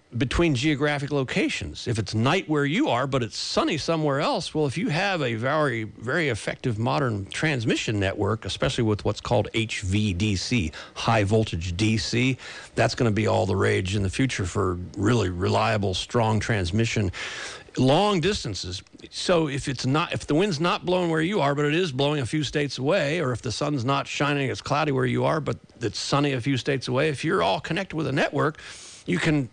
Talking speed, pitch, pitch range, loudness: 195 wpm, 130 Hz, 110-150 Hz, -25 LUFS